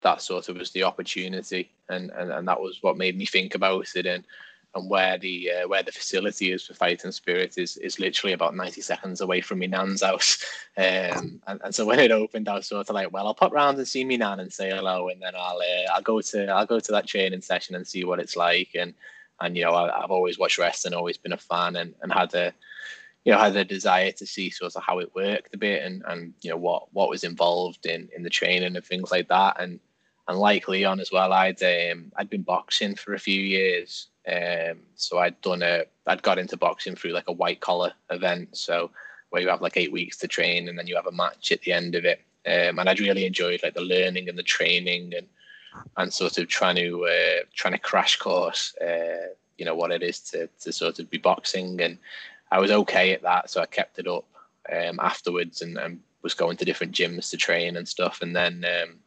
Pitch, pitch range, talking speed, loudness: 95 Hz, 90-100 Hz, 245 wpm, -25 LUFS